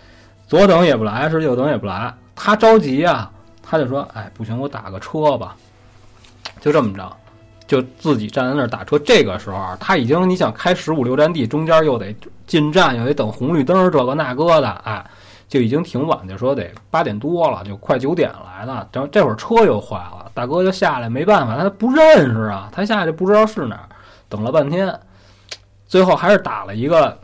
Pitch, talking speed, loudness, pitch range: 125 Hz, 295 characters per minute, -16 LUFS, 105-160 Hz